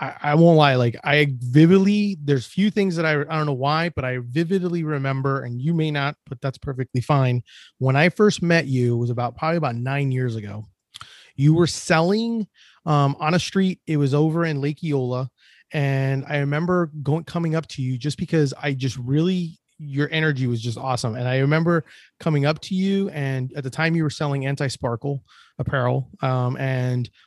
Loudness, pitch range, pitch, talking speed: -22 LUFS, 130-160 Hz, 145 Hz, 200 wpm